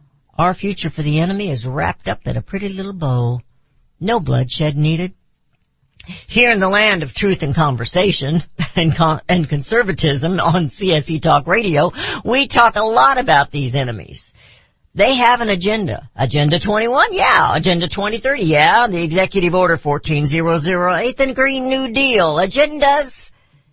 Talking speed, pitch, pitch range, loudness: 145 wpm, 175 Hz, 150-210 Hz, -15 LUFS